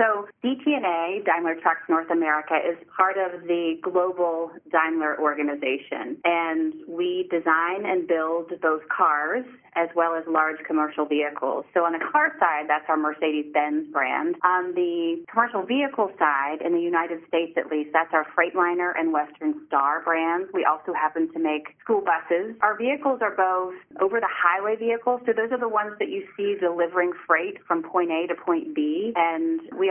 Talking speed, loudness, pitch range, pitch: 170 wpm, -24 LUFS, 160-225 Hz, 175 Hz